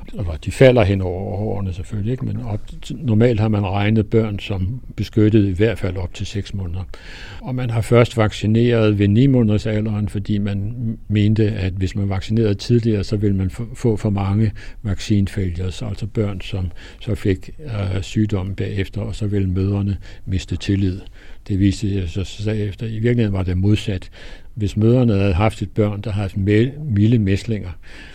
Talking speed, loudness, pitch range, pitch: 165 wpm, -20 LUFS, 95-110 Hz, 105 Hz